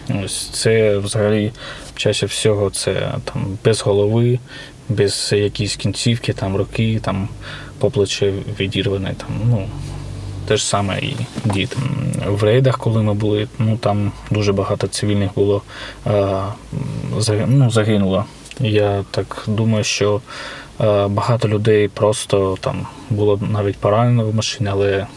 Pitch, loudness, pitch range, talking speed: 105 Hz, -18 LUFS, 100-130 Hz, 125 wpm